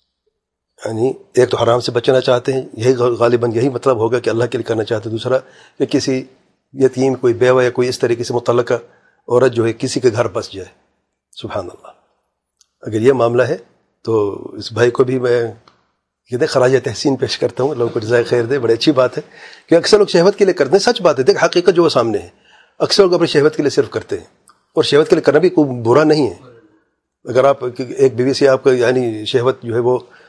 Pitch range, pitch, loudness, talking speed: 120-160 Hz, 130 Hz, -15 LUFS, 230 wpm